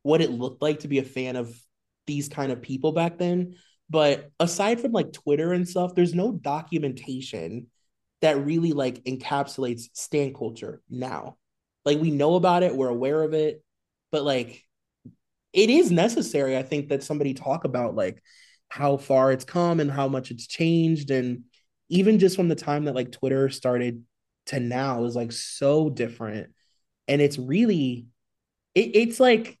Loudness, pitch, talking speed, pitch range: -24 LUFS, 140 Hz, 170 wpm, 125-160 Hz